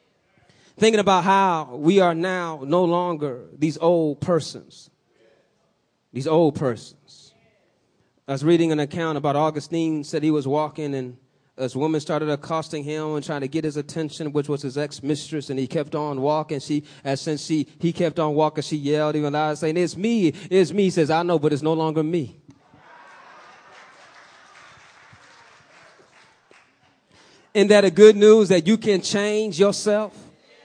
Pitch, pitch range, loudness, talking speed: 155 Hz, 150-175 Hz, -21 LUFS, 160 wpm